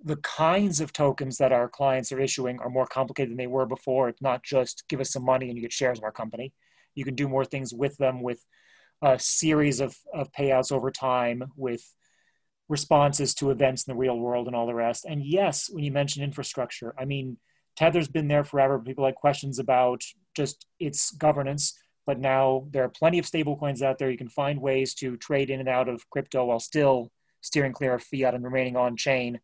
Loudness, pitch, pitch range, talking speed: -26 LUFS, 135 Hz, 125-145 Hz, 220 wpm